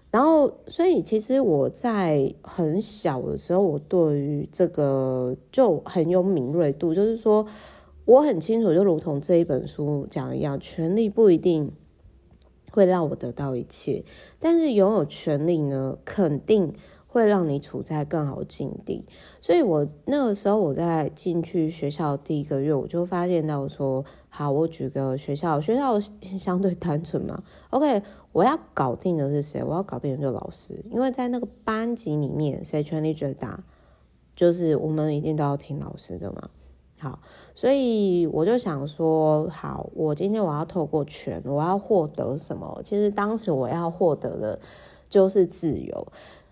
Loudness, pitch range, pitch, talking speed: -24 LUFS, 145-200 Hz, 165 Hz, 245 characters per minute